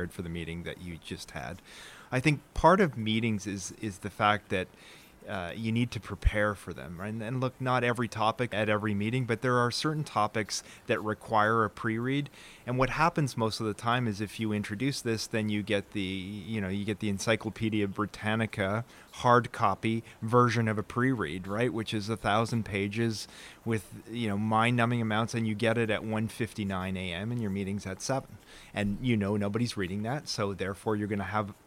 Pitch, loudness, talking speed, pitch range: 110 Hz, -30 LUFS, 205 wpm, 100-115 Hz